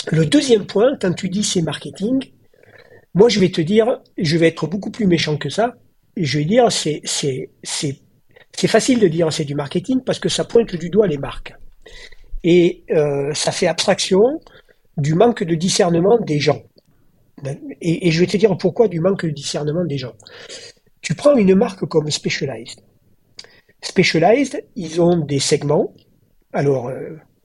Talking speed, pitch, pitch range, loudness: 175 wpm, 180 Hz, 150-220 Hz, -17 LUFS